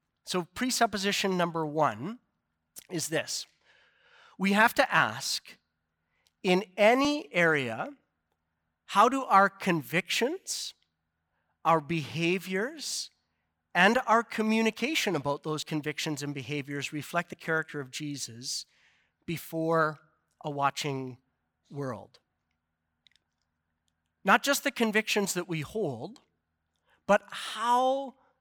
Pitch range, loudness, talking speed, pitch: 135-210 Hz, -28 LUFS, 95 wpm, 160 Hz